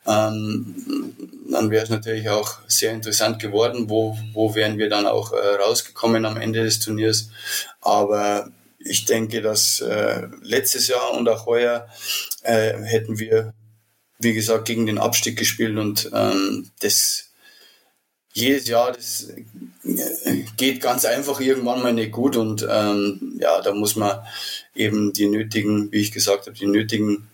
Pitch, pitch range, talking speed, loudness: 110 Hz, 105-115 Hz, 150 wpm, -21 LUFS